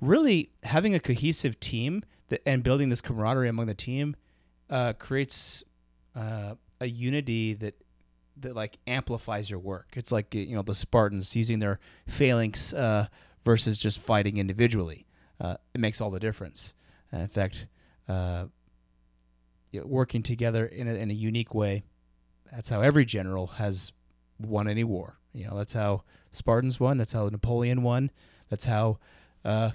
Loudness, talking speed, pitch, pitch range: -29 LUFS, 150 wpm, 110 Hz, 95-120 Hz